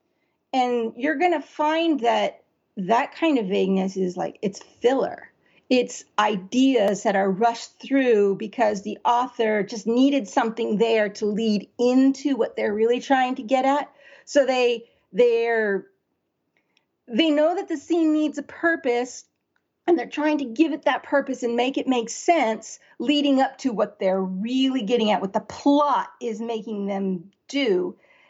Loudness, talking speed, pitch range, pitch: -23 LUFS, 160 wpm, 220-285 Hz, 245 Hz